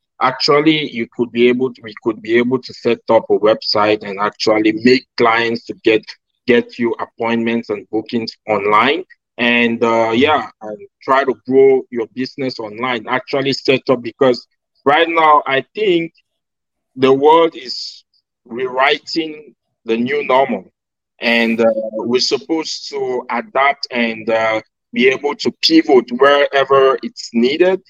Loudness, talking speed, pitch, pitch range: -15 LUFS, 145 wpm, 125 Hz, 115-145 Hz